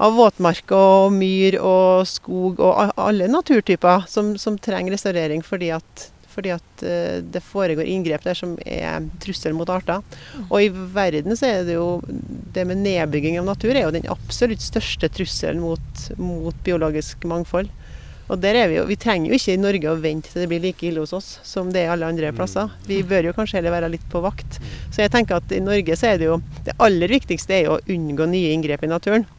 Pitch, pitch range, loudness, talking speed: 180 Hz, 165-195 Hz, -20 LUFS, 215 wpm